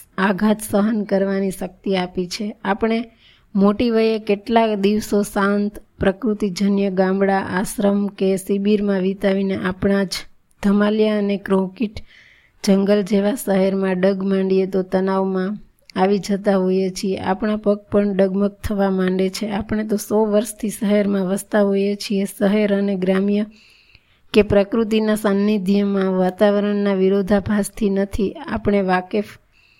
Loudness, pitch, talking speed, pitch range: -19 LUFS, 200 Hz, 120 wpm, 195-210 Hz